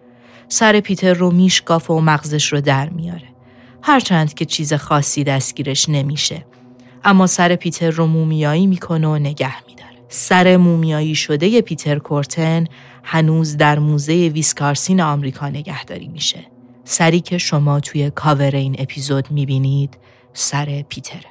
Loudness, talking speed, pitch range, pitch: -16 LUFS, 130 wpm, 135-165 Hz, 150 Hz